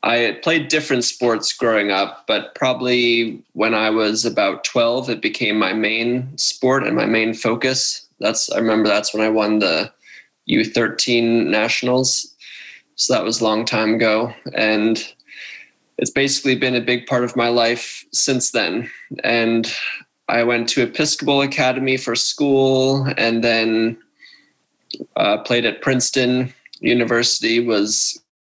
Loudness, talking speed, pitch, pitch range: -18 LUFS, 140 wpm, 120 Hz, 110-130 Hz